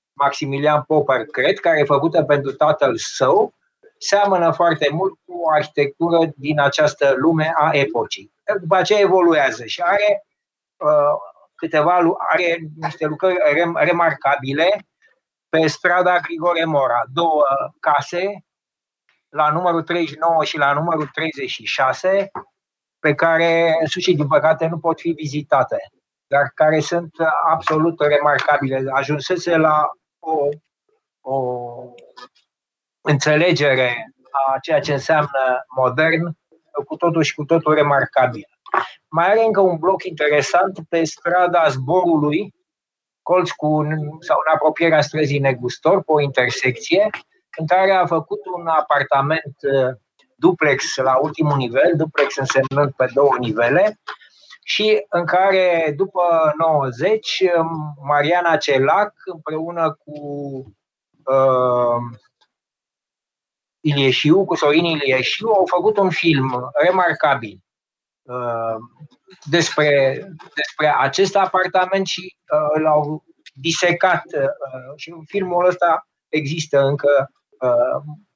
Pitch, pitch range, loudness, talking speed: 155 Hz, 145-175 Hz, -18 LUFS, 110 wpm